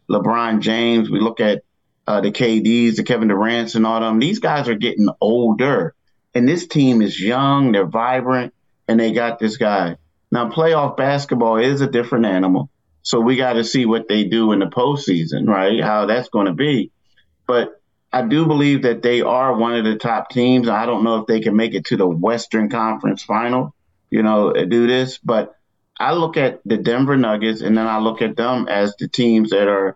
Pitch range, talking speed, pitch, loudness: 110-125 Hz, 205 wpm, 115 Hz, -17 LUFS